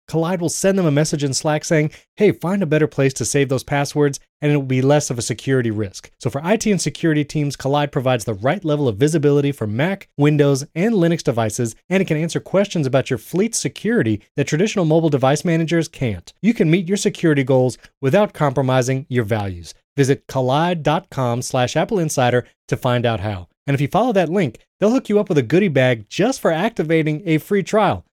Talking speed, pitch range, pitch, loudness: 210 wpm, 130-175 Hz, 150 Hz, -19 LUFS